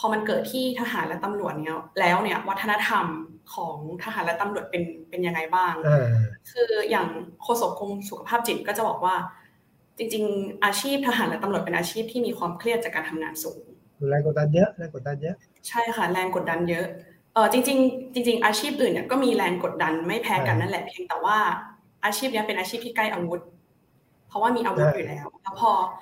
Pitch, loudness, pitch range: 200 Hz, -25 LUFS, 170-235 Hz